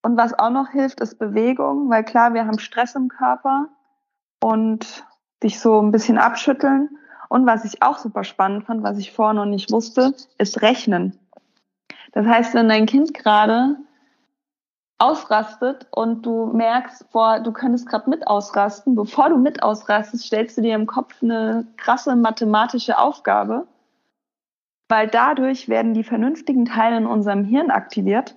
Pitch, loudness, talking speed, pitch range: 230 Hz, -19 LUFS, 155 wpm, 220-265 Hz